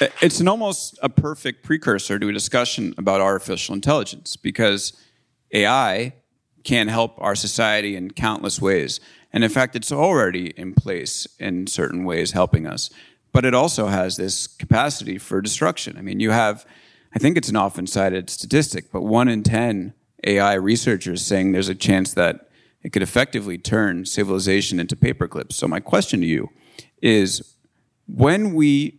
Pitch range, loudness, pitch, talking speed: 95-125 Hz, -20 LUFS, 105 Hz, 160 wpm